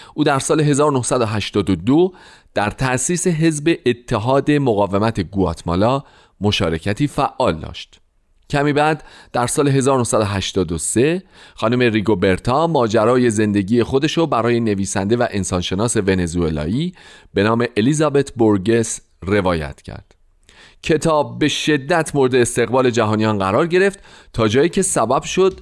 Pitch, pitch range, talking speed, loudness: 120 Hz, 105-150 Hz, 110 wpm, -17 LUFS